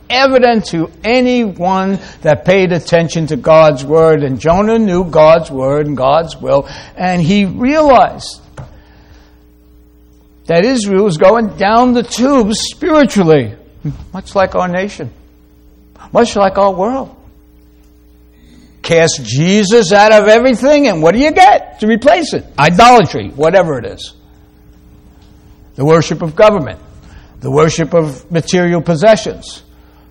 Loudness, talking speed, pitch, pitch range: -10 LUFS, 125 wpm, 165 Hz, 130-210 Hz